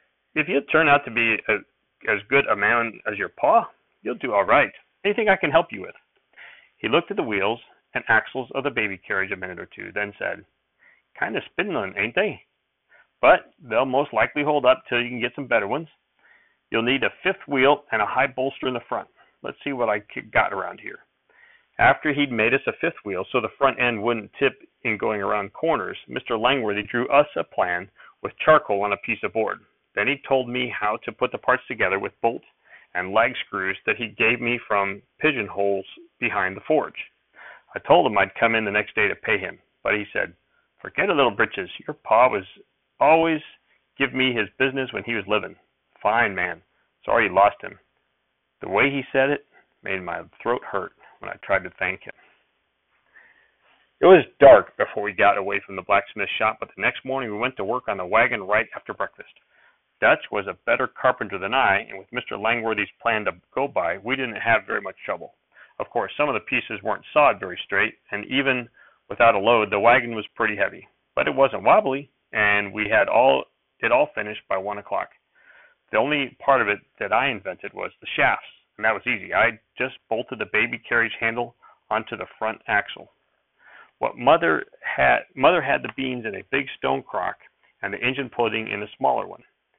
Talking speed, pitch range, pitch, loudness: 210 wpm, 105-135 Hz, 120 Hz, -22 LUFS